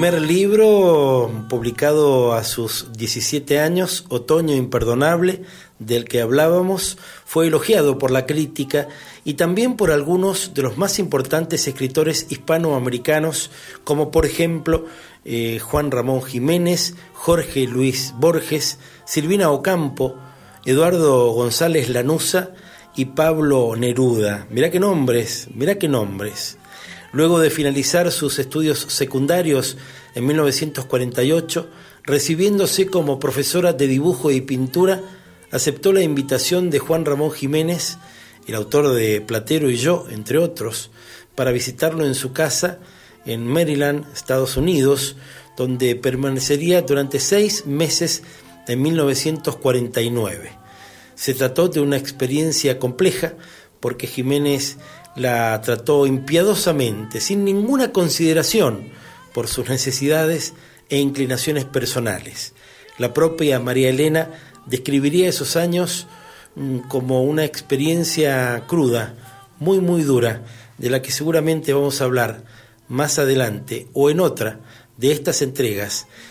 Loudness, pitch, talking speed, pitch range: -19 LUFS, 145 Hz, 115 wpm, 130-165 Hz